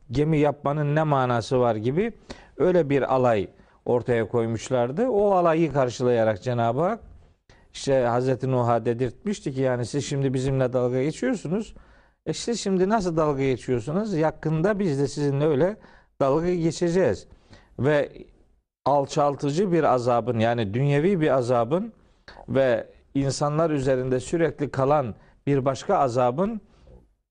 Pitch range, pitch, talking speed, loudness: 125-165 Hz, 140 Hz, 125 wpm, -24 LUFS